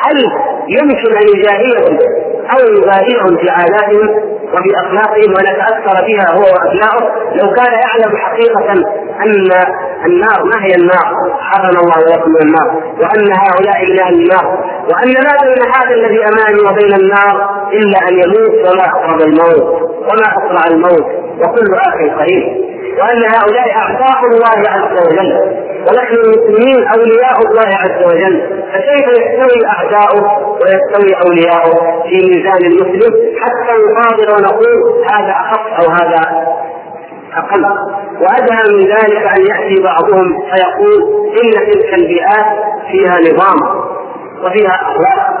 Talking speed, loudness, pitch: 125 wpm, -9 LUFS, 215 Hz